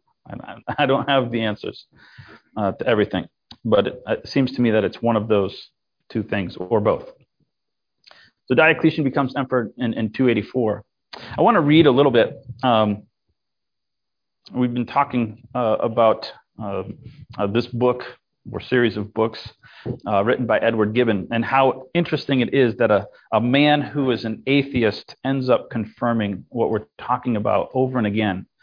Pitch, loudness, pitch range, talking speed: 120 Hz, -20 LUFS, 110-135 Hz, 165 wpm